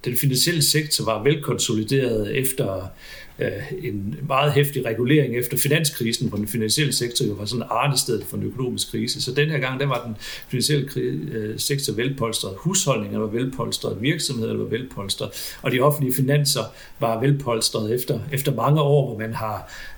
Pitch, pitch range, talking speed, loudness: 130 Hz, 115-145 Hz, 160 wpm, -22 LUFS